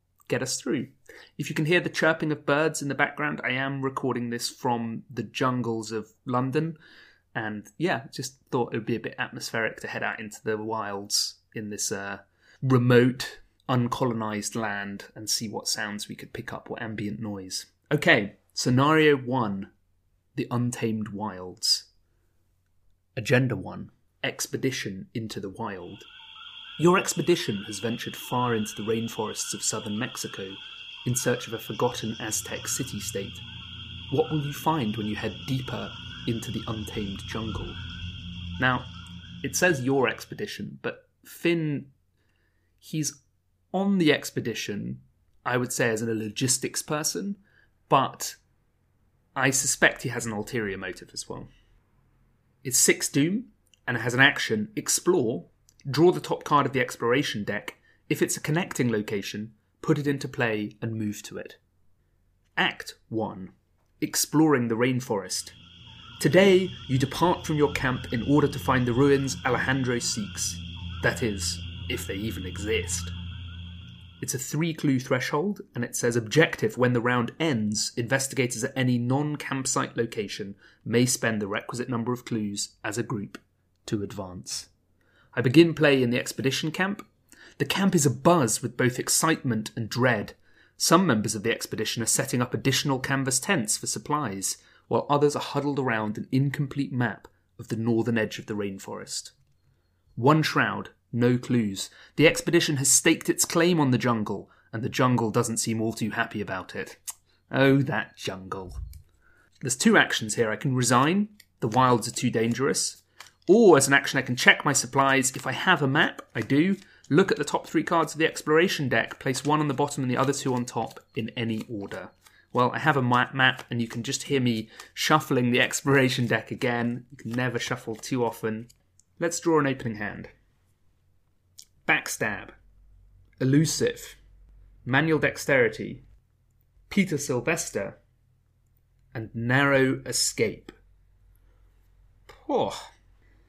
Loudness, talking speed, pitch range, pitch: -26 LUFS, 155 wpm, 105-140 Hz, 120 Hz